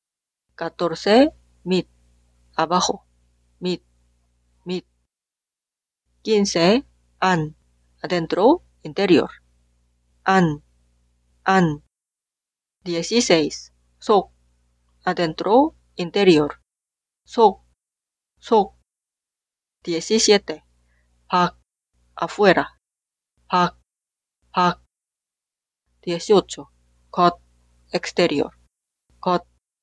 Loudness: -20 LUFS